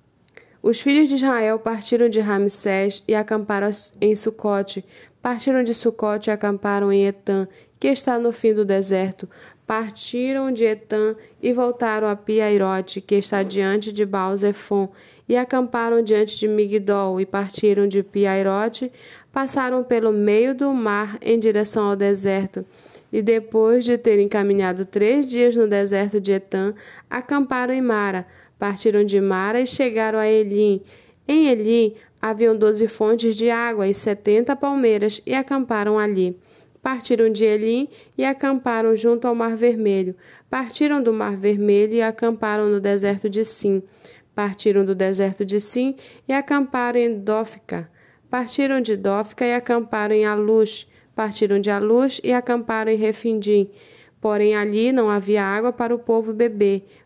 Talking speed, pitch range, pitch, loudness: 145 wpm, 205-235 Hz, 215 Hz, -20 LUFS